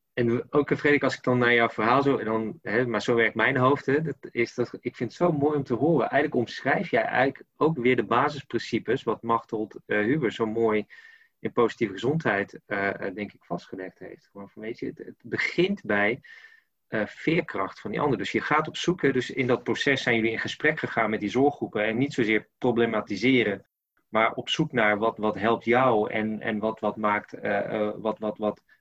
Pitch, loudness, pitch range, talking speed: 115 Hz, -26 LUFS, 110-135 Hz, 210 wpm